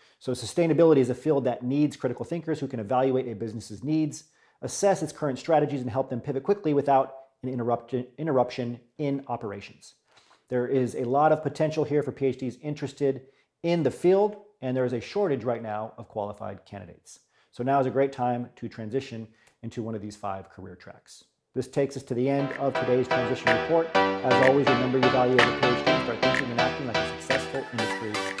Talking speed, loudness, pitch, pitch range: 195 wpm, -26 LUFS, 130 Hz, 120-145 Hz